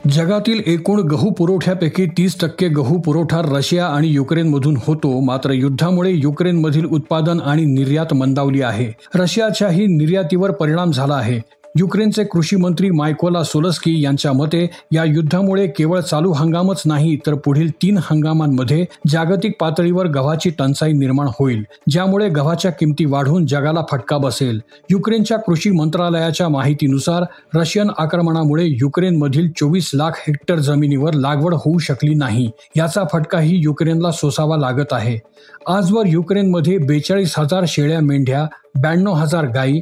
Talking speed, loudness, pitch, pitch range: 130 wpm, -16 LUFS, 160 Hz, 145-180 Hz